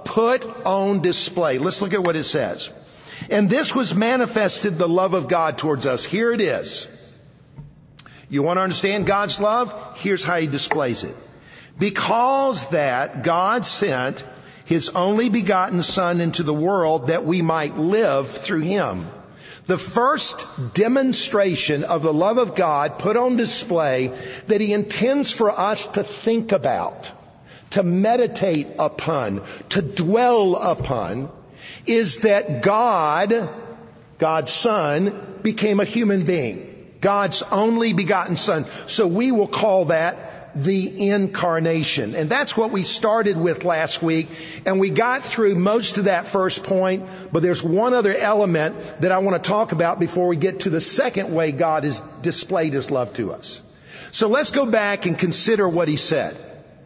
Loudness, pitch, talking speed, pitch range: -20 LUFS, 190 Hz, 155 wpm, 160-210 Hz